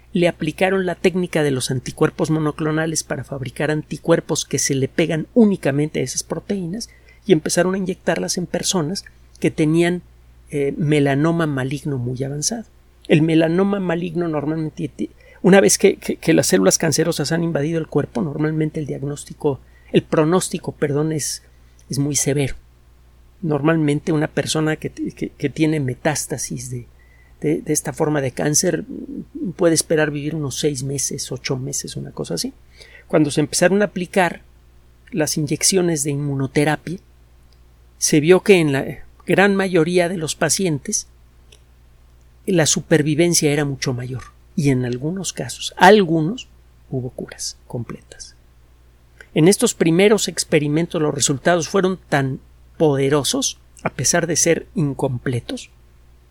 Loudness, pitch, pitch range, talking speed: -19 LUFS, 155 Hz, 135-170 Hz, 140 wpm